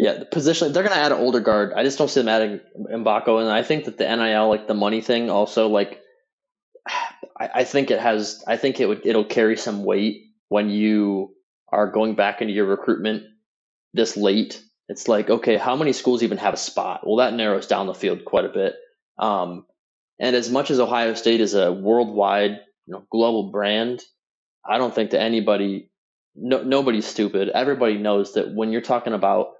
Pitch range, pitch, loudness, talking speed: 105-125 Hz, 110 Hz, -21 LUFS, 200 wpm